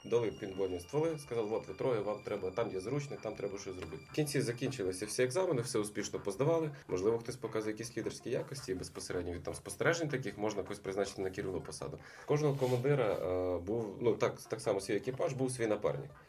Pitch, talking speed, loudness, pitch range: 115 Hz, 200 wpm, -36 LUFS, 100-140 Hz